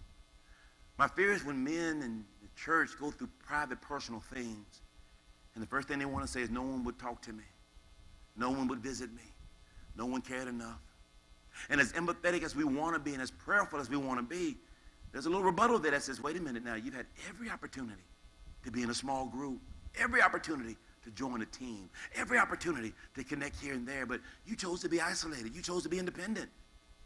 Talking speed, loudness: 215 wpm, -36 LUFS